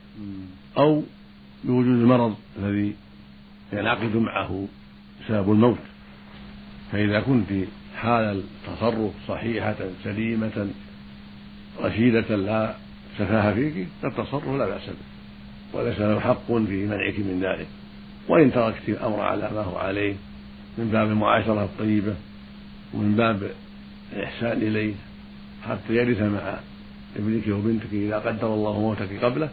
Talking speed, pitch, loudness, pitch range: 110 wpm, 100 Hz, -24 LUFS, 70-110 Hz